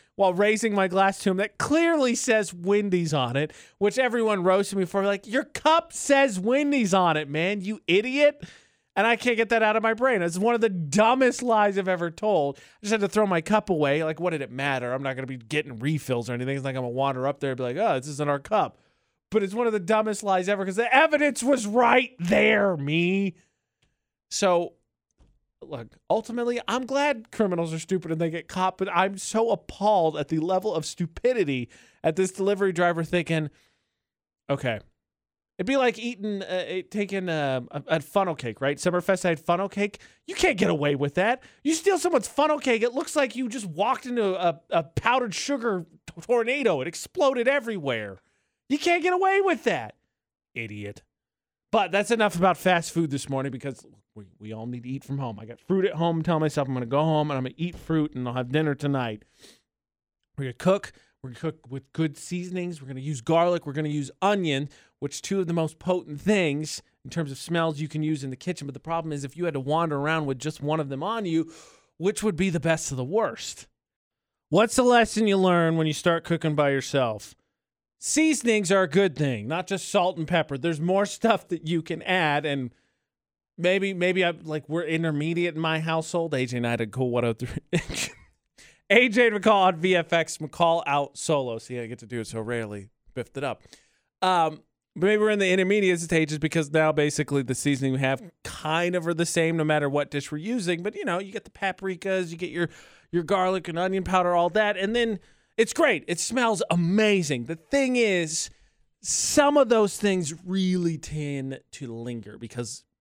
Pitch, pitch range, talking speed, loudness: 175 Hz, 150-210 Hz, 215 wpm, -25 LUFS